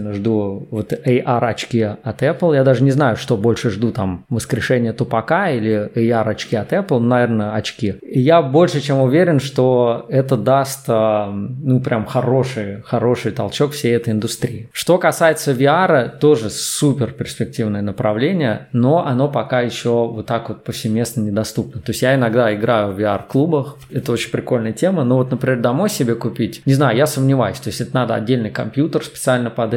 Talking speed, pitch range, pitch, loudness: 165 wpm, 110-135 Hz, 120 Hz, -17 LUFS